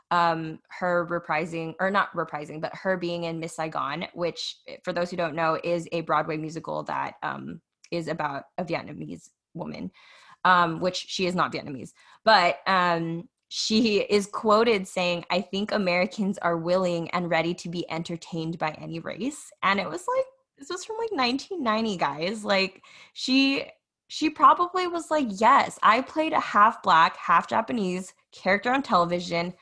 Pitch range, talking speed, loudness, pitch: 165-215 Hz, 165 wpm, -25 LUFS, 180 Hz